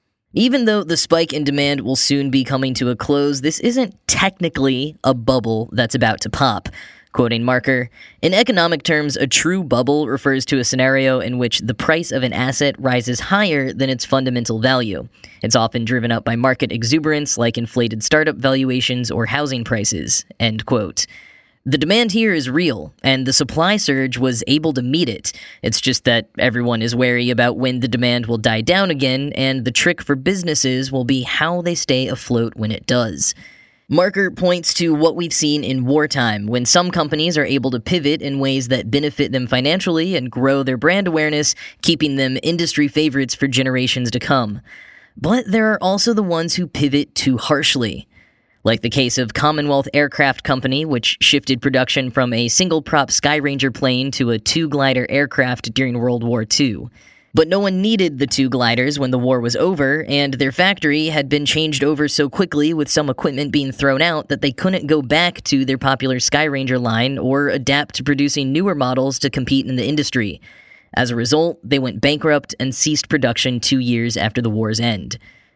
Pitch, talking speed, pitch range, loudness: 135 Hz, 185 wpm, 125-150 Hz, -17 LUFS